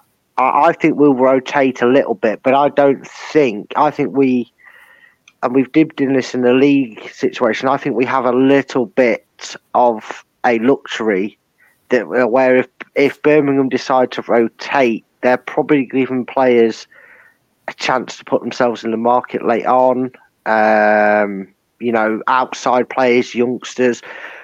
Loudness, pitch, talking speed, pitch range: -15 LUFS, 130 Hz, 150 wpm, 120-140 Hz